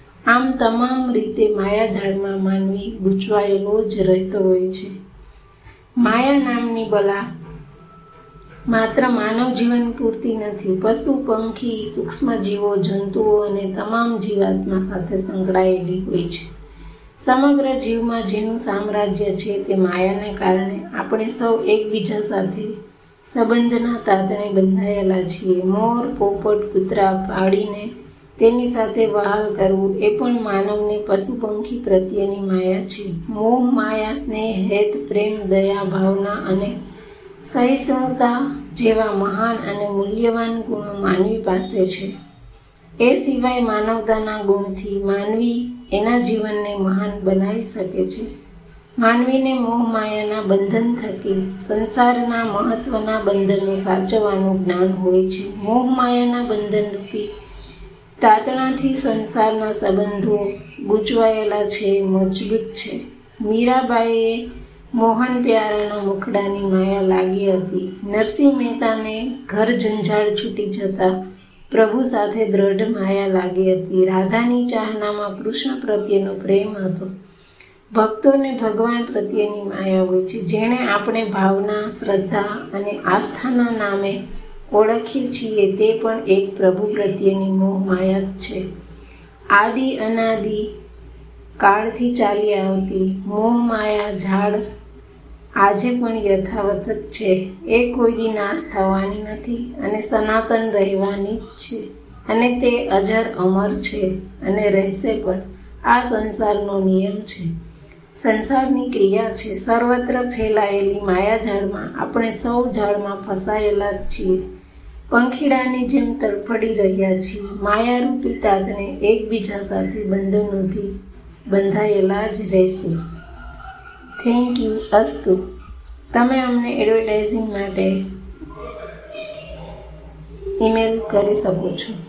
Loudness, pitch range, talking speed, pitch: -19 LUFS, 195-225 Hz, 100 wpm, 210 Hz